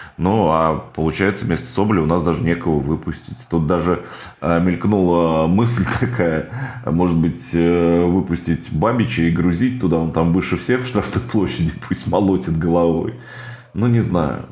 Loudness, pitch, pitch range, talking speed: -18 LUFS, 85 Hz, 85-105 Hz, 145 wpm